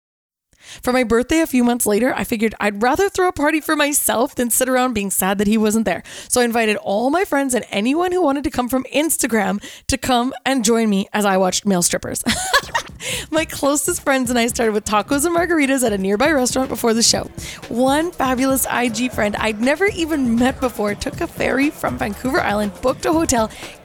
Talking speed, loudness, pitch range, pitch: 210 wpm, -18 LUFS, 220-285 Hz, 250 Hz